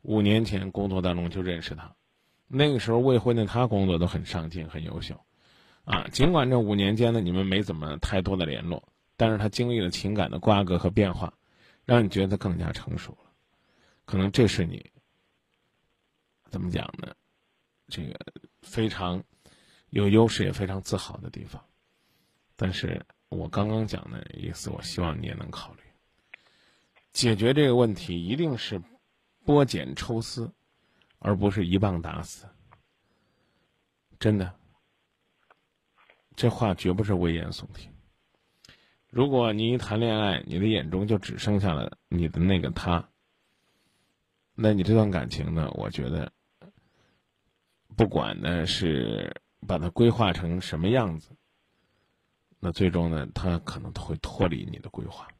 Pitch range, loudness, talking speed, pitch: 90-110 Hz, -27 LUFS, 215 characters per minute, 100 Hz